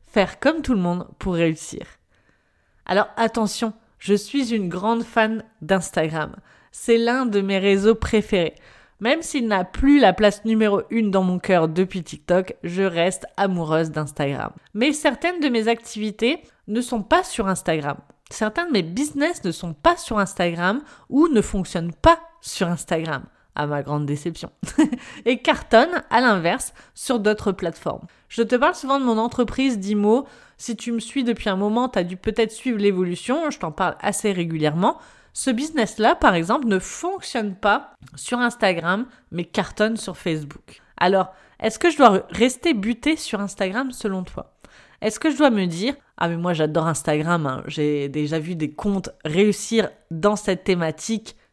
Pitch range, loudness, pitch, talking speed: 180-240 Hz, -22 LUFS, 210 Hz, 170 wpm